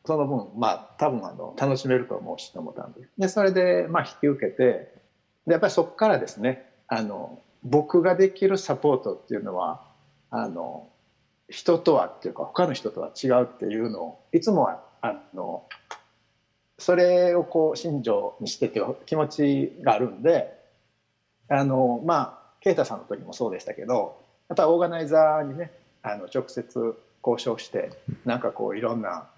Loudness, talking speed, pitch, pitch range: -25 LUFS, 305 characters per minute, 140 Hz, 115-175 Hz